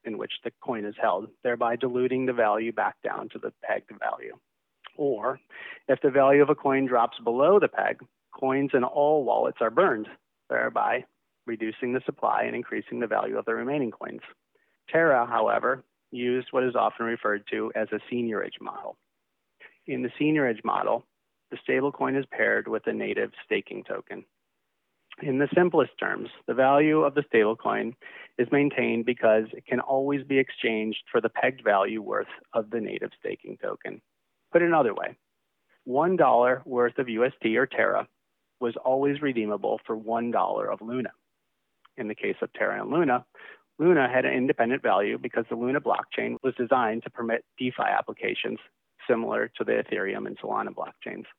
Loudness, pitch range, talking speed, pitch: -26 LUFS, 115-135 Hz, 170 wpm, 125 Hz